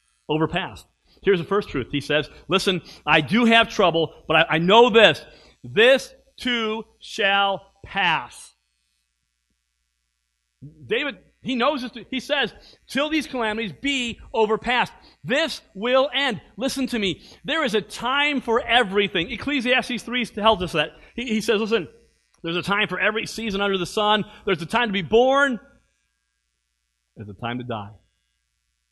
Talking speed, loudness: 150 wpm, -21 LUFS